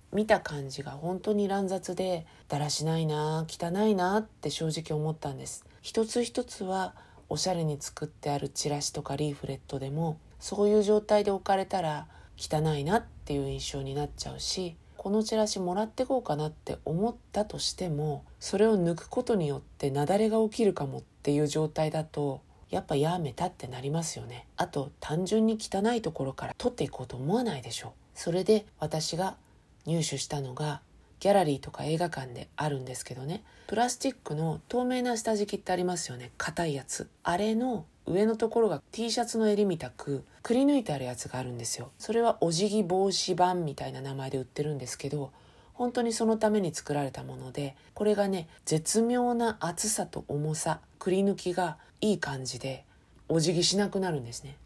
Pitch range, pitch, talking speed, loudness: 145-210 Hz, 165 Hz, 380 characters per minute, -30 LUFS